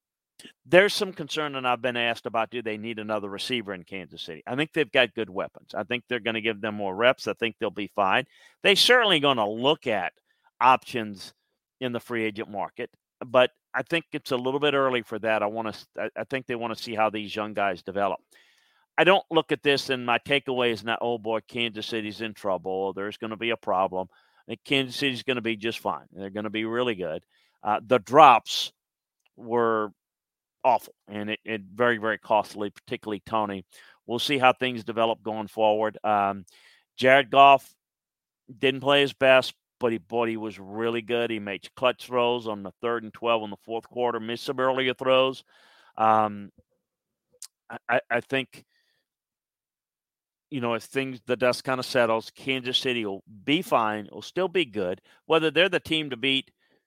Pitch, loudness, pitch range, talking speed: 120 Hz, -25 LUFS, 110-130 Hz, 200 wpm